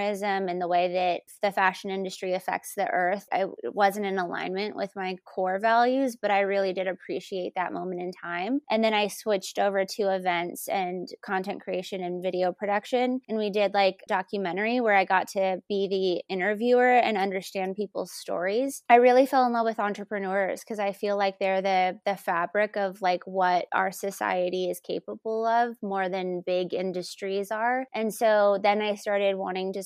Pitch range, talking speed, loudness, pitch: 185-210 Hz, 185 wpm, -27 LUFS, 195 Hz